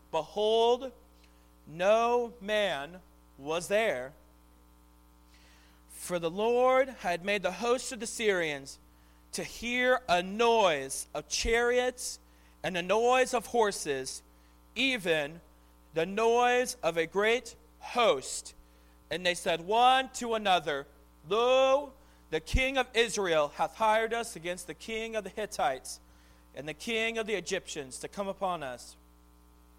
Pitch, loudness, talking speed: 180 Hz, -30 LUFS, 125 wpm